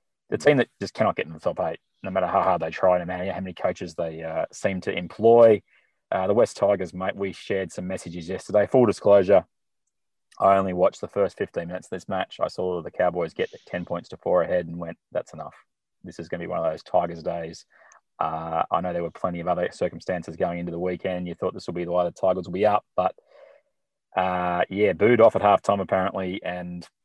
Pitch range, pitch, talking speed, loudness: 85-95 Hz, 90 Hz, 235 wpm, -24 LUFS